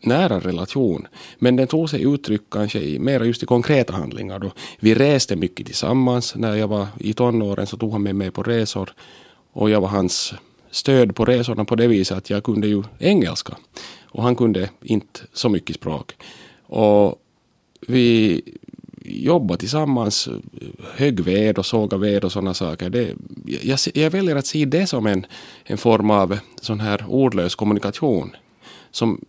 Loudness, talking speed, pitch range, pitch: -20 LUFS, 170 wpm, 100-125 Hz, 110 Hz